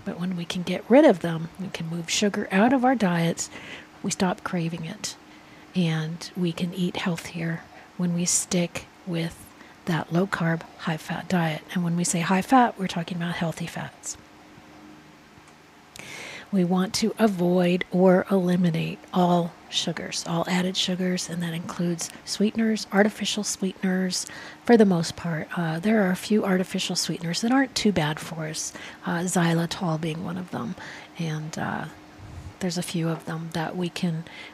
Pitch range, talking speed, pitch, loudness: 170-190 Hz, 165 wpm, 180 Hz, -25 LUFS